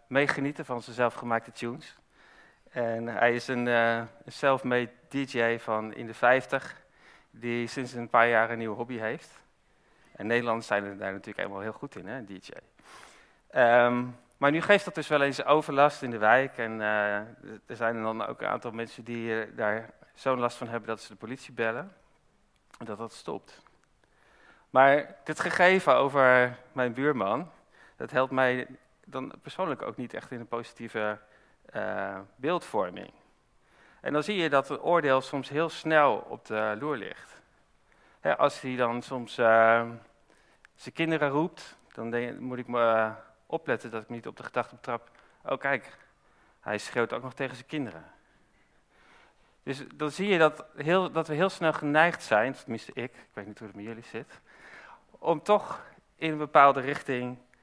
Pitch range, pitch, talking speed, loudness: 115-140 Hz, 125 Hz, 175 wpm, -28 LUFS